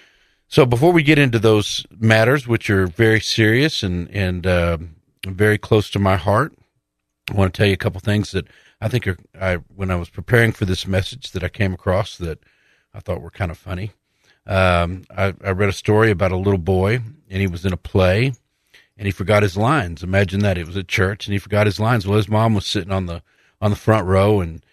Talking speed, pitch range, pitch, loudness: 230 wpm, 95-110 Hz, 100 Hz, -19 LUFS